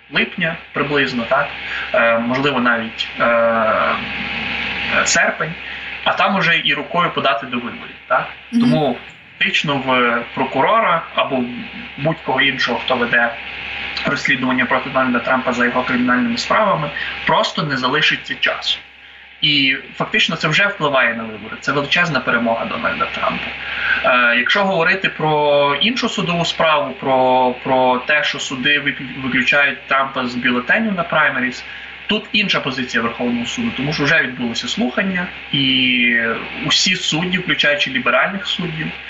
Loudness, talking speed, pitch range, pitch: -16 LUFS, 130 wpm, 125-155 Hz, 135 Hz